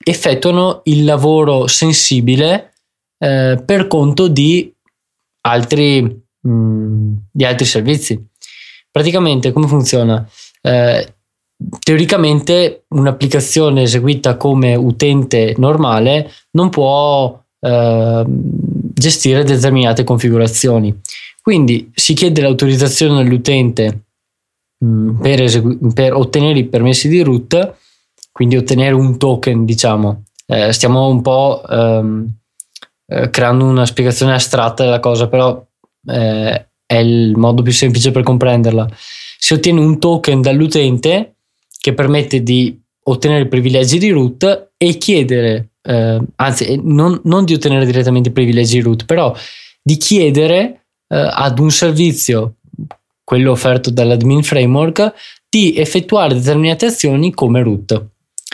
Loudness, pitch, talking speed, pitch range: -12 LUFS, 130 Hz, 115 wpm, 120-150 Hz